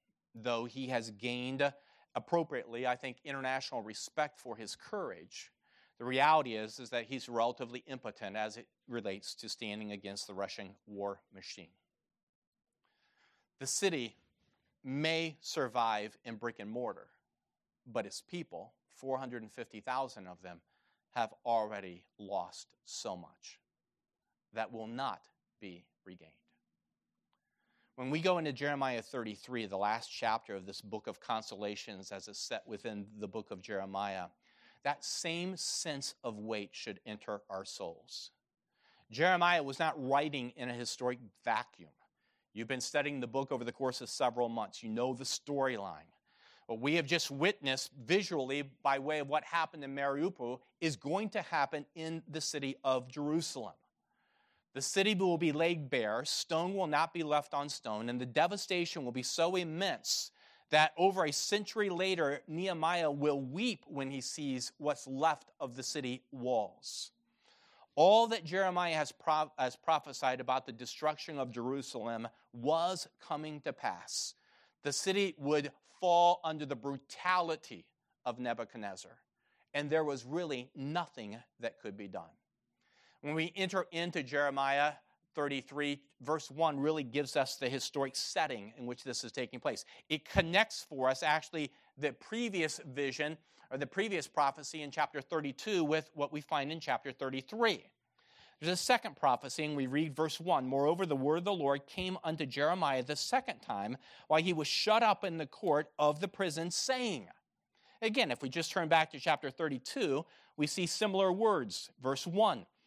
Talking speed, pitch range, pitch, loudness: 155 wpm, 125-160 Hz, 140 Hz, -36 LUFS